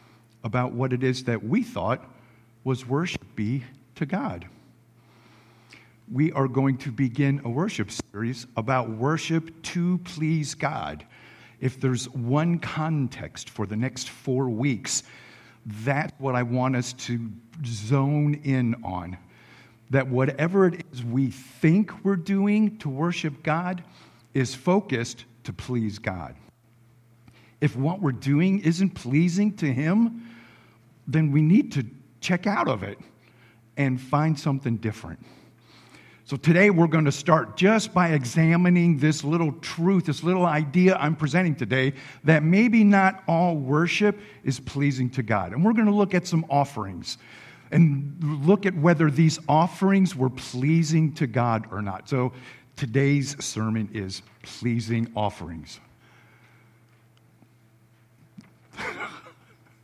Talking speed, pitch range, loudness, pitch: 130 wpm, 120-160 Hz, -24 LUFS, 135 Hz